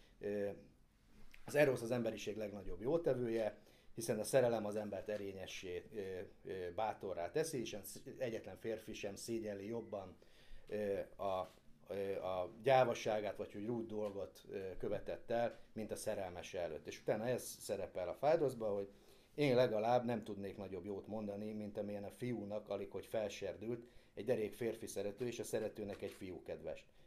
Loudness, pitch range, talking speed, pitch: -42 LUFS, 100-115 Hz, 145 wpm, 105 Hz